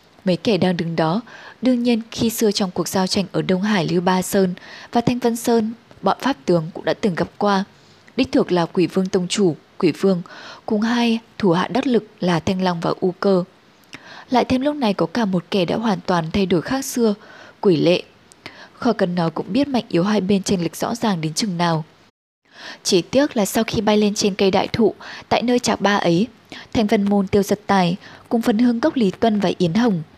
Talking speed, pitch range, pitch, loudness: 230 wpm, 180-230 Hz, 205 Hz, -20 LUFS